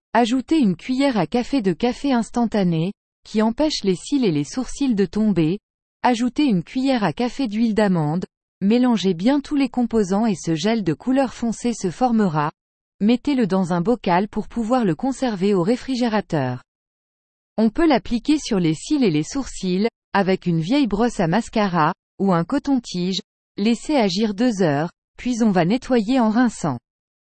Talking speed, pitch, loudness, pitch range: 165 wpm, 225 Hz, -21 LUFS, 185-250 Hz